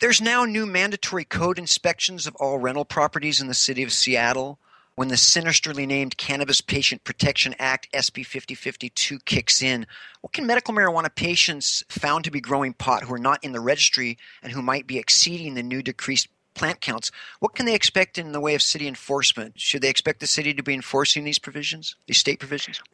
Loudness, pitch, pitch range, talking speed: -21 LUFS, 140 Hz, 130-170 Hz, 195 wpm